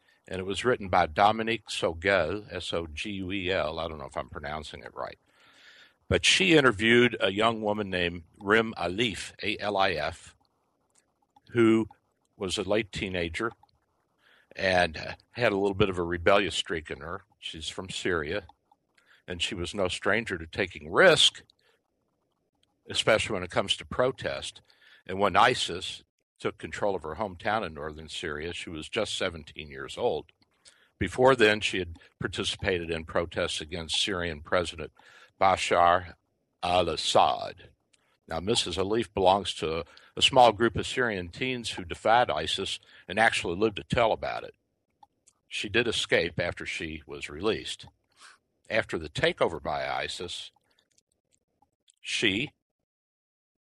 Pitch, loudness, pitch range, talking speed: 95 Hz, -27 LUFS, 85-110 Hz, 135 wpm